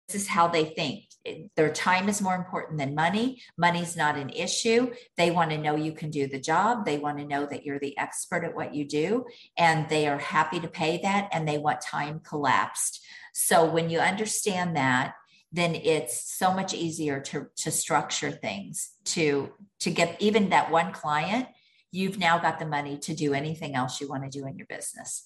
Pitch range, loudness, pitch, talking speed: 150-185 Hz, -27 LUFS, 165 Hz, 205 wpm